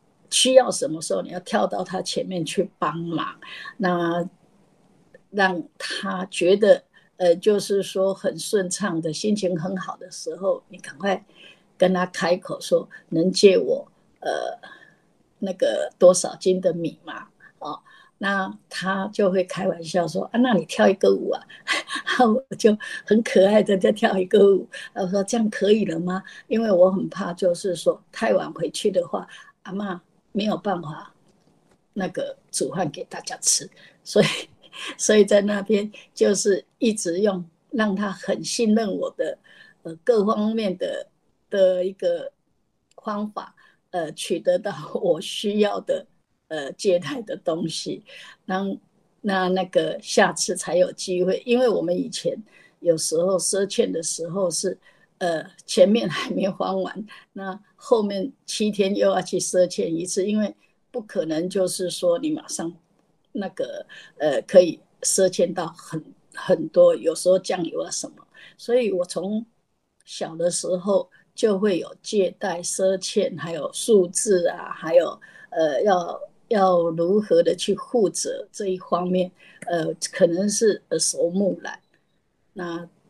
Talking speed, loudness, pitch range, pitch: 205 characters per minute, -23 LUFS, 180-220 Hz, 195 Hz